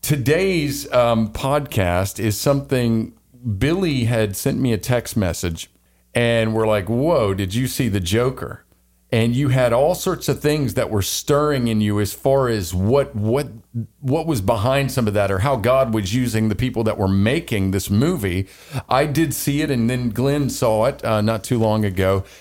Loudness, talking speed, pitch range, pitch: -20 LUFS, 185 wpm, 105-135 Hz, 115 Hz